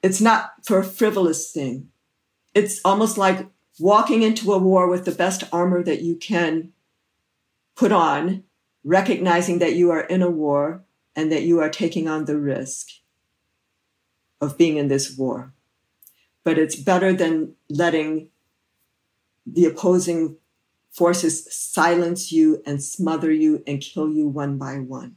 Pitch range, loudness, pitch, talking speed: 150-180 Hz, -20 LUFS, 165 Hz, 145 wpm